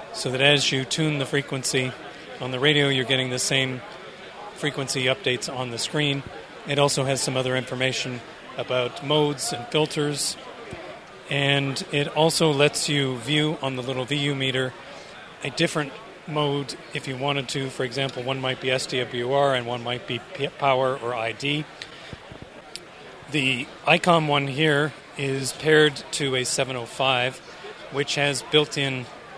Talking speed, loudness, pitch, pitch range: 150 wpm, -23 LUFS, 140 Hz, 130-150 Hz